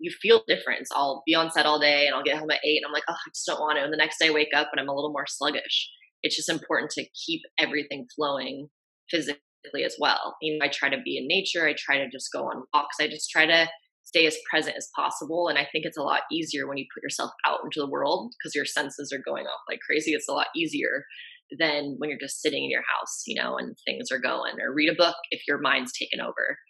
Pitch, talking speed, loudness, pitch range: 150 Hz, 275 wpm, -26 LUFS, 145-170 Hz